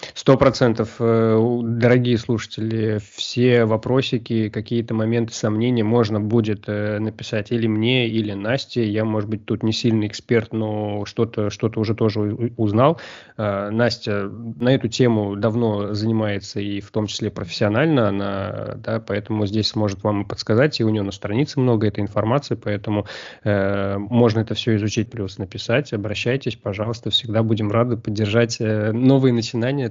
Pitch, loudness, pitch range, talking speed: 110 Hz, -21 LUFS, 105-120 Hz, 140 wpm